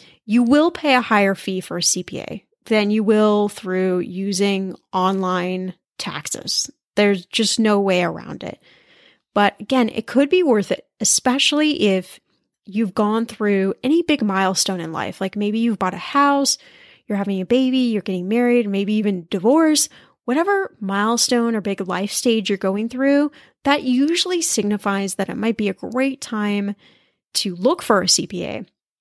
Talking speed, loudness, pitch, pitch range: 165 wpm, -19 LUFS, 210 Hz, 195-255 Hz